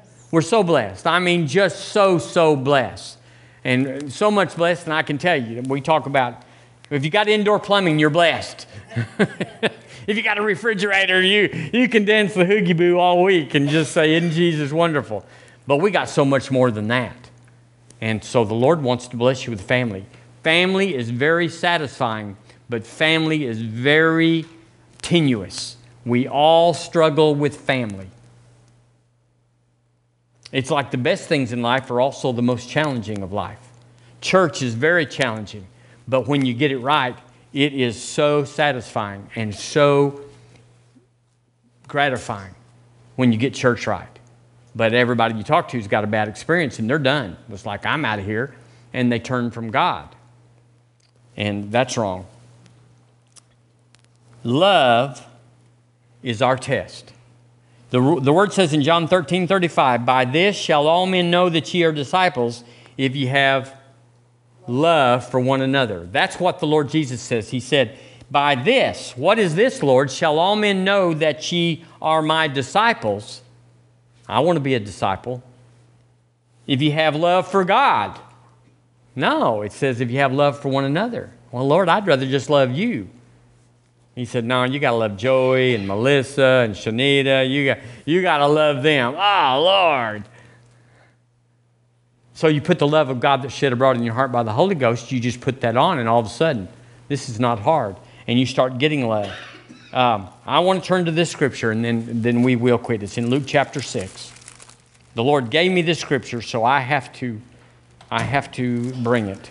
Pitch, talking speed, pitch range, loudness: 125 Hz, 170 wpm, 120-150 Hz, -19 LUFS